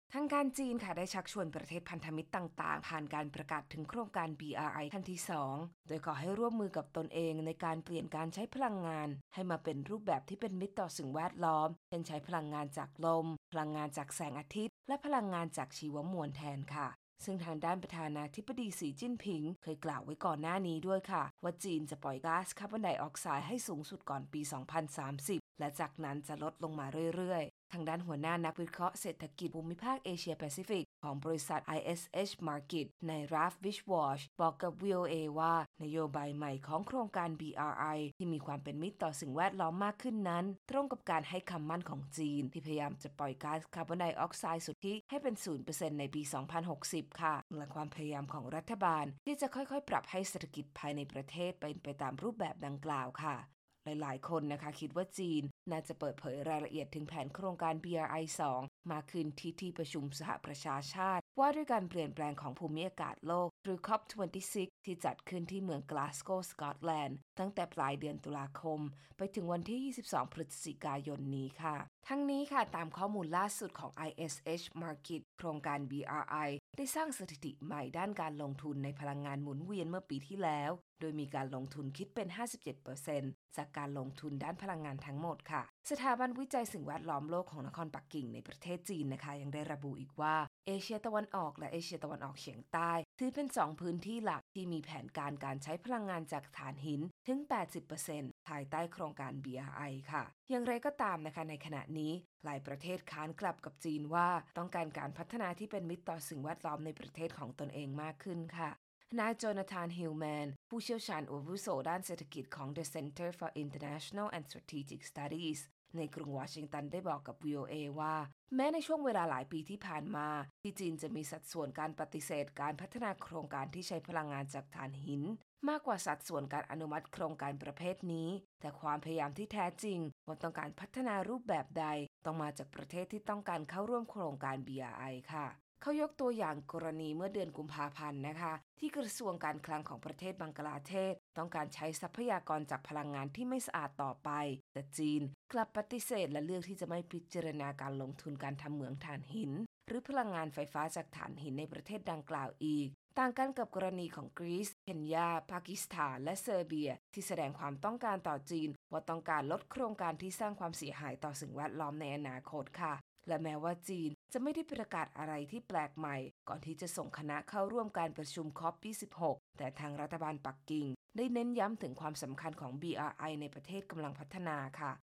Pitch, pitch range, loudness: 160 Hz, 150-185 Hz, -41 LUFS